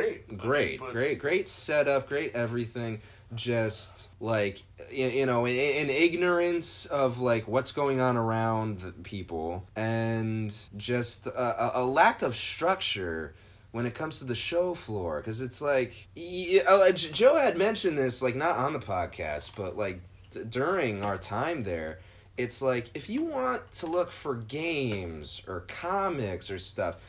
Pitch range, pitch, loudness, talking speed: 105-155 Hz, 120 Hz, -29 LUFS, 145 wpm